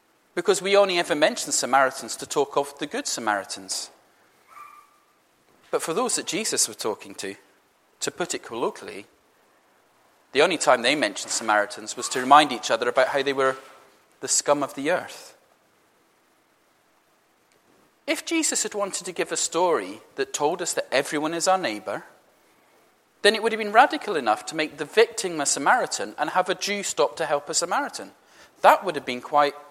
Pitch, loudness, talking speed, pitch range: 175 Hz, -23 LUFS, 175 wpm, 140-220 Hz